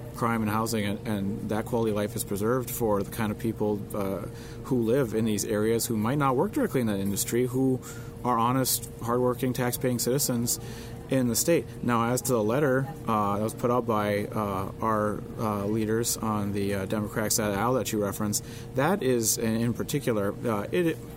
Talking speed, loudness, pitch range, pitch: 195 wpm, -27 LUFS, 105-120 Hz, 115 Hz